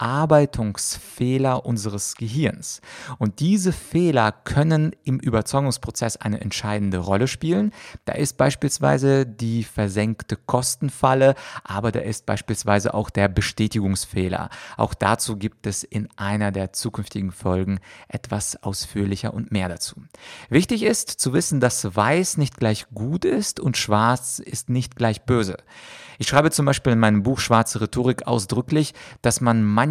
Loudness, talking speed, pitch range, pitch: -22 LUFS, 140 wpm, 105-130 Hz, 115 Hz